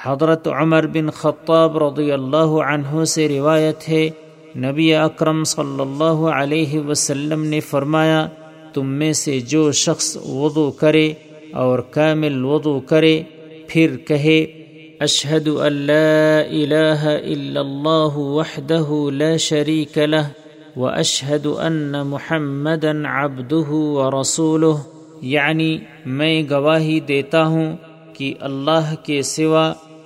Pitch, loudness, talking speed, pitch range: 155 Hz, -17 LUFS, 110 wpm, 145-160 Hz